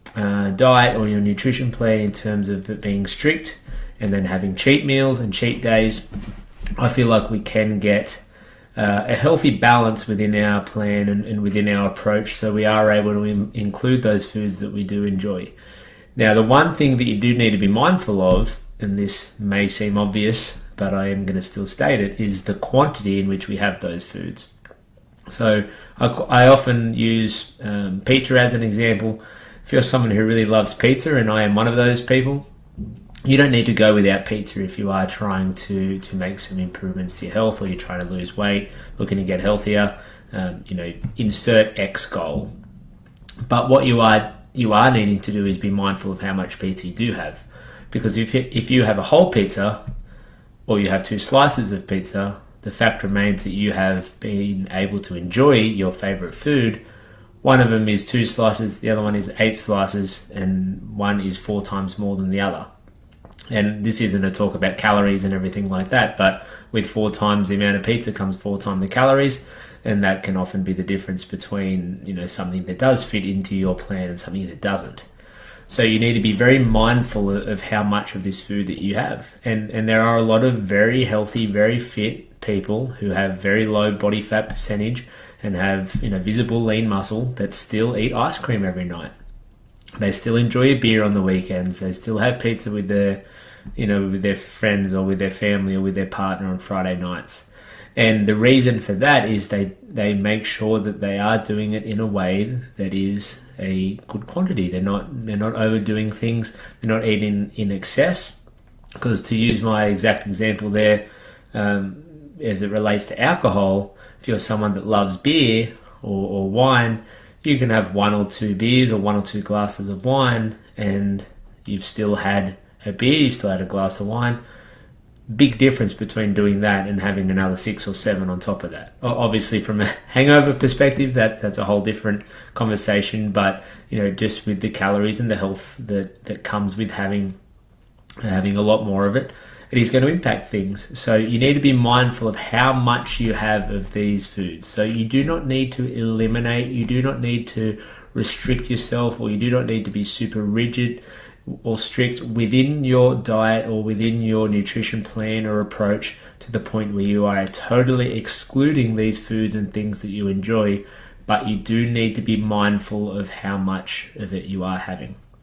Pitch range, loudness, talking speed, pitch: 100-115 Hz, -20 LUFS, 200 wpm, 105 Hz